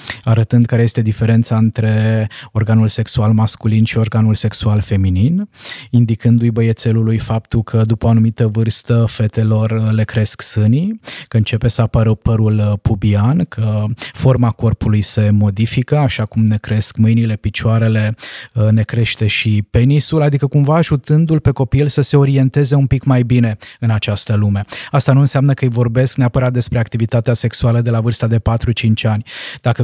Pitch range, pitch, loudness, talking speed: 110-125 Hz, 115 Hz, -14 LUFS, 155 wpm